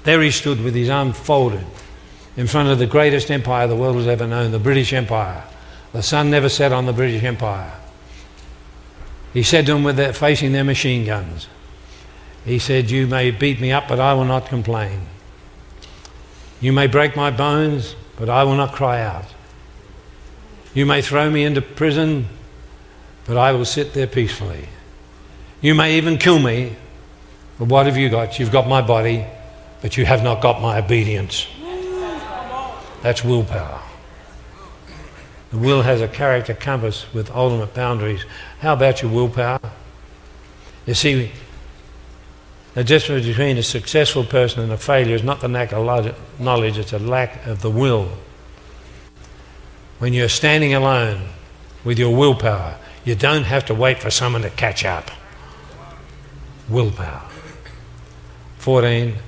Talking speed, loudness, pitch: 155 wpm, -18 LUFS, 120 Hz